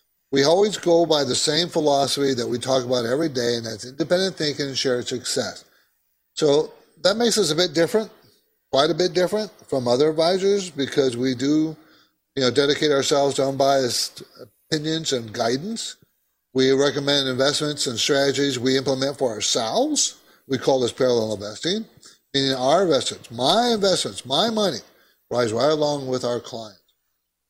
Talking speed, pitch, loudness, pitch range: 160 wpm, 140 Hz, -21 LUFS, 130-165 Hz